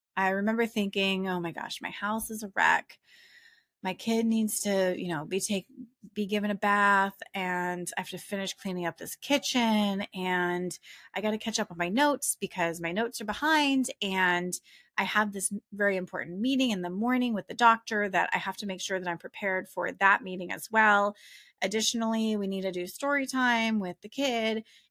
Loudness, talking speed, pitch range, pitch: -29 LUFS, 200 wpm, 185-225 Hz, 205 Hz